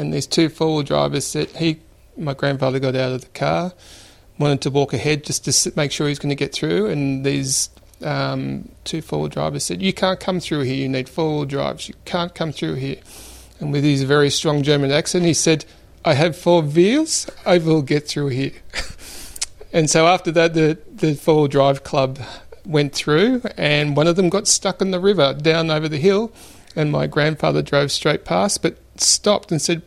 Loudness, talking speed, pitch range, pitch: -19 LUFS, 205 wpm, 140-170 Hz, 150 Hz